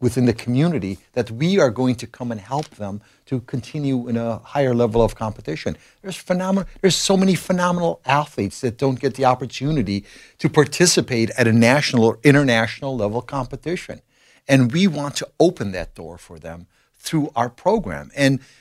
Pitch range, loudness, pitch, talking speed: 115-150 Hz, -20 LUFS, 130 Hz, 175 wpm